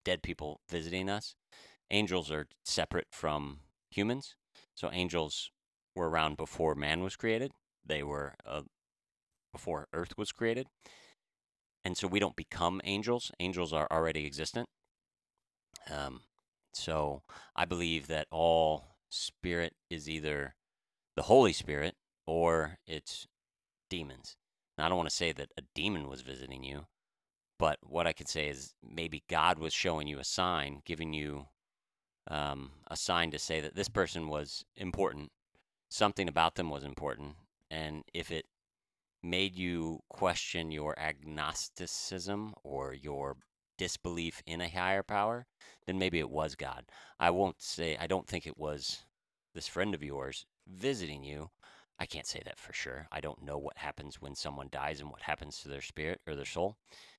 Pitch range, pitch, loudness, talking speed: 75-90 Hz, 80 Hz, -36 LUFS, 155 wpm